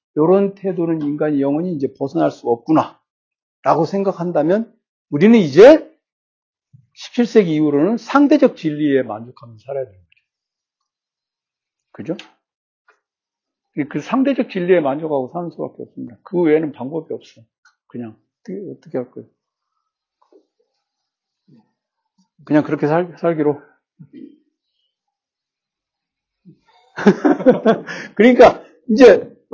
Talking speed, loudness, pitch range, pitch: 230 characters per minute, -15 LUFS, 150-245 Hz, 175 Hz